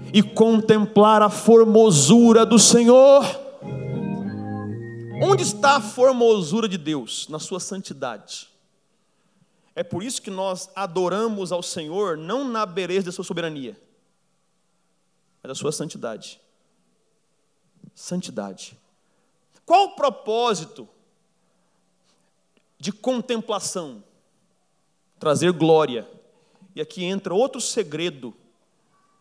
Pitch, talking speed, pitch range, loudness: 195 Hz, 95 wpm, 165-225 Hz, -19 LUFS